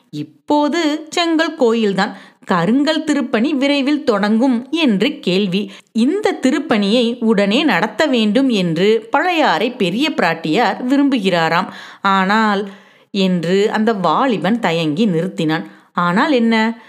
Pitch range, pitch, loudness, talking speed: 195-275 Hz, 230 Hz, -16 LUFS, 95 wpm